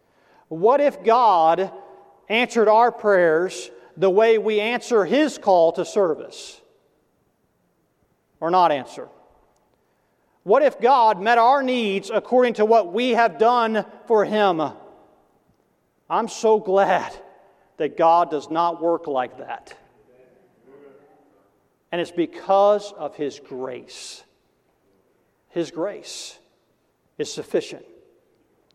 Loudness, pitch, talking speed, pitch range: -20 LUFS, 210 Hz, 105 wpm, 170-235 Hz